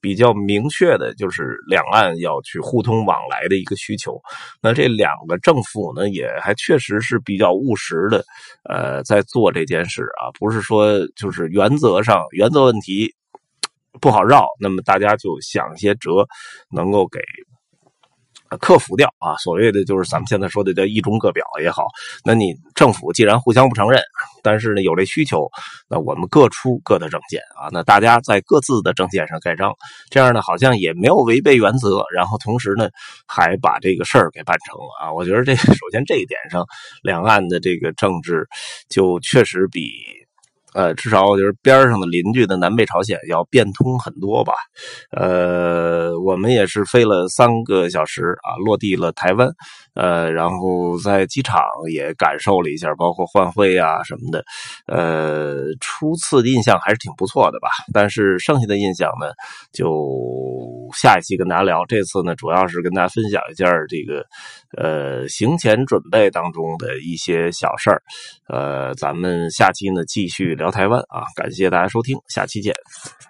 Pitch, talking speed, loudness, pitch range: 100 Hz, 260 characters per minute, -17 LUFS, 90-115 Hz